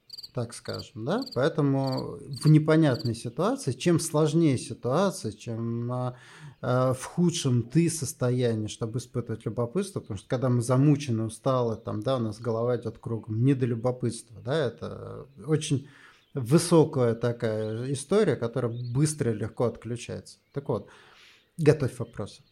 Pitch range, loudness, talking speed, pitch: 115-145 Hz, -27 LUFS, 130 wpm, 125 Hz